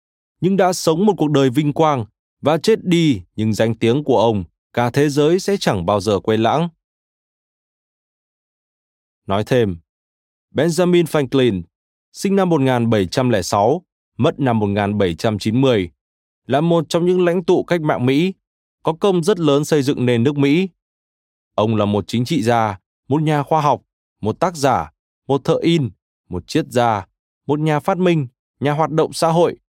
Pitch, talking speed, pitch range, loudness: 135 Hz, 165 wpm, 105-160 Hz, -18 LUFS